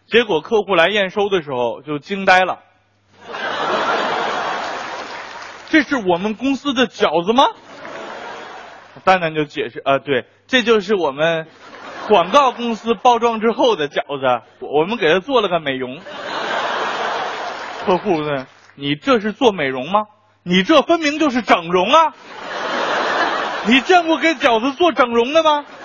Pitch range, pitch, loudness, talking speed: 165-275 Hz, 220 Hz, -17 LUFS, 200 characters per minute